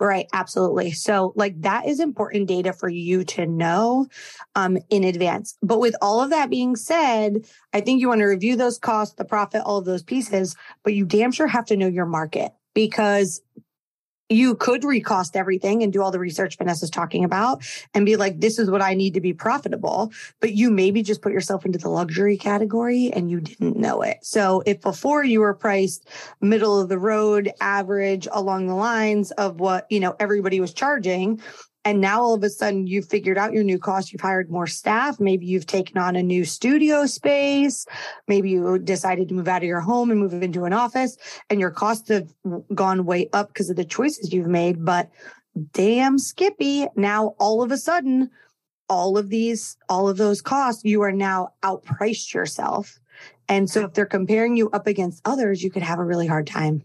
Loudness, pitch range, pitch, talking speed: -21 LUFS, 185-220 Hz, 200 Hz, 205 wpm